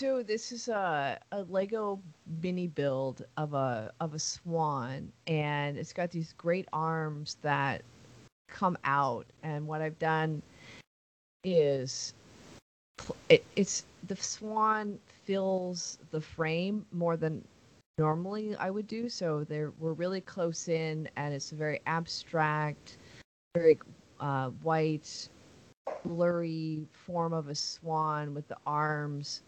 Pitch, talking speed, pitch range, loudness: 160 Hz, 125 wpm, 150-180 Hz, -33 LUFS